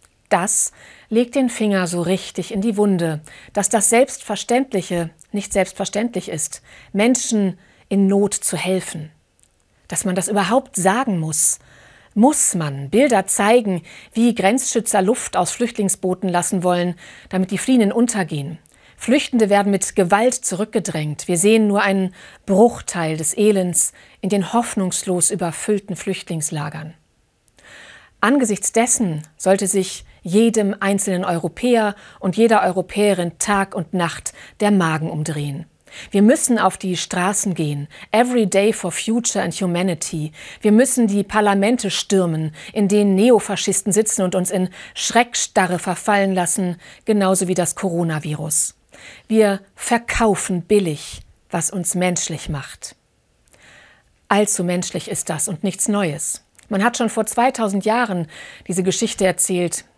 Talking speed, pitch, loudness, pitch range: 130 wpm, 195 Hz, -18 LUFS, 175-215 Hz